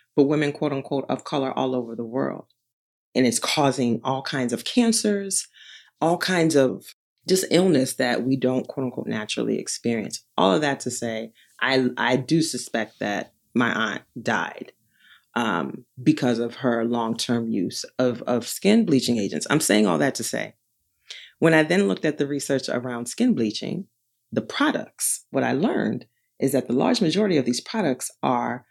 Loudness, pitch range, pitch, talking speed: -23 LUFS, 120-155 Hz, 130 Hz, 175 wpm